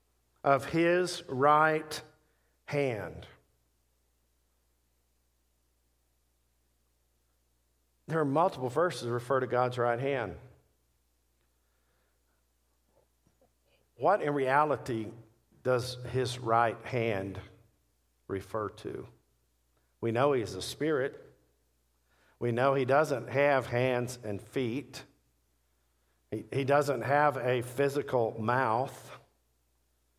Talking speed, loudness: 85 wpm, -30 LUFS